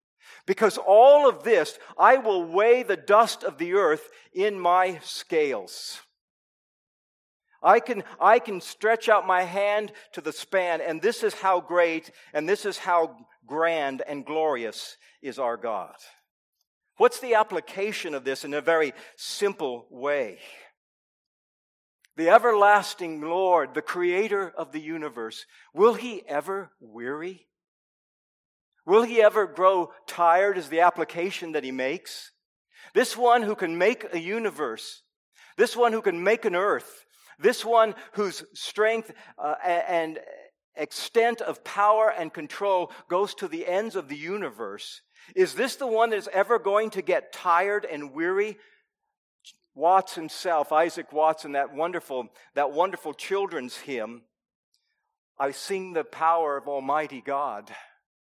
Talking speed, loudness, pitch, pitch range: 140 wpm, -25 LUFS, 190 Hz, 160-225 Hz